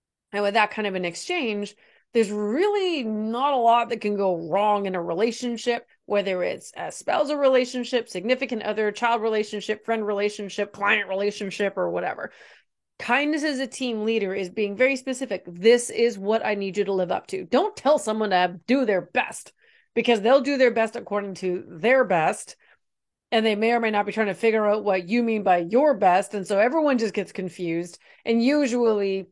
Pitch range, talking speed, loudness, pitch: 200-245 Hz, 190 wpm, -23 LUFS, 220 Hz